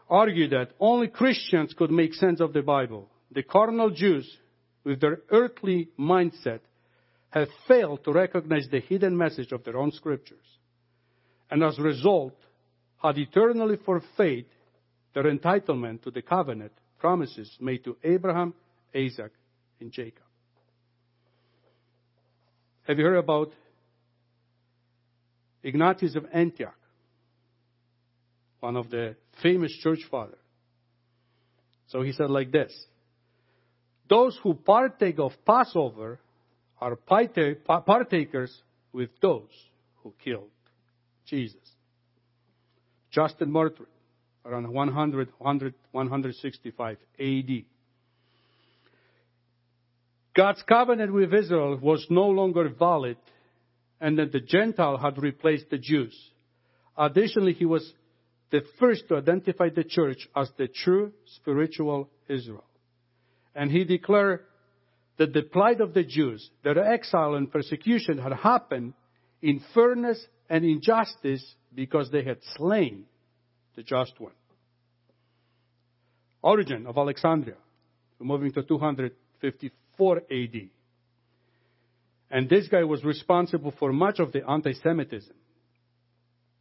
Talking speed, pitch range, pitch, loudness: 110 wpm, 120-160 Hz, 135 Hz, -25 LUFS